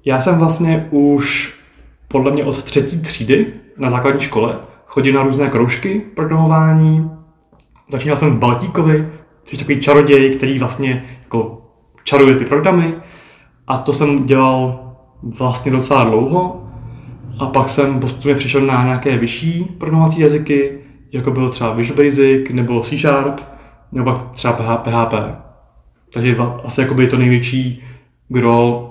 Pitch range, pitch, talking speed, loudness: 125-145 Hz, 135 Hz, 135 wpm, -14 LUFS